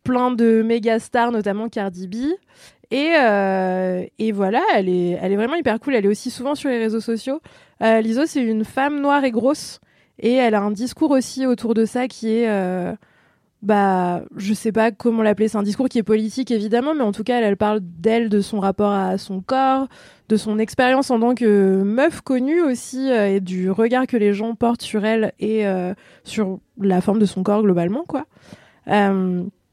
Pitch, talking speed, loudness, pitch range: 225 Hz, 210 wpm, -19 LUFS, 205-250 Hz